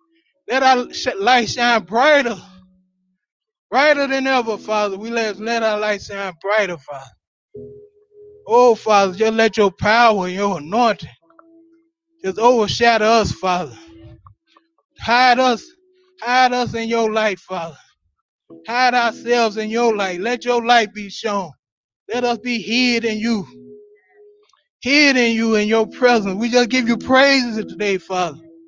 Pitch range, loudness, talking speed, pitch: 205-260 Hz, -17 LUFS, 140 wpm, 230 Hz